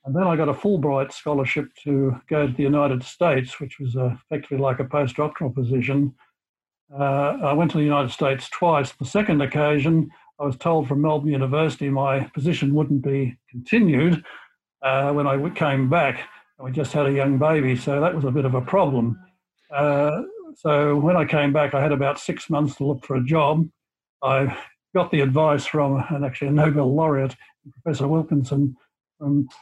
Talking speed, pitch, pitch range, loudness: 185 wpm, 145 Hz, 135-155 Hz, -22 LUFS